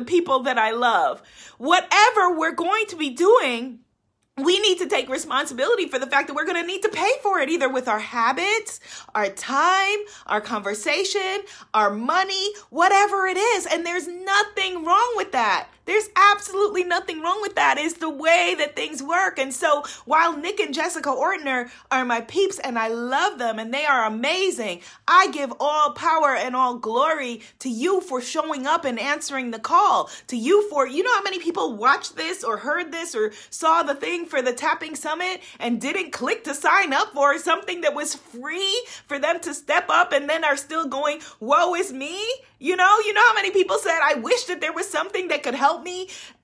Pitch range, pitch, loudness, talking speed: 275-380 Hz, 325 Hz, -21 LUFS, 200 wpm